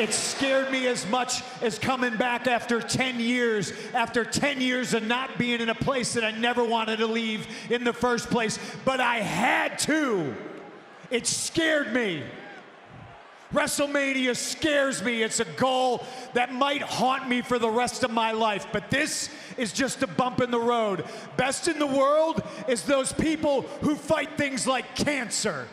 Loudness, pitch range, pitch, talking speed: -26 LUFS, 230-265 Hz, 245 Hz, 175 wpm